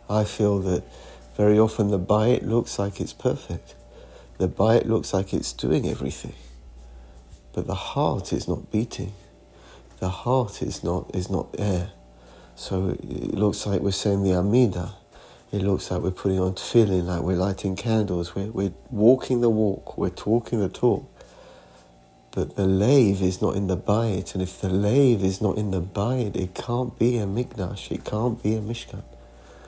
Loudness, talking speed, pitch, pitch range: -24 LUFS, 175 wpm, 100 Hz, 90-110 Hz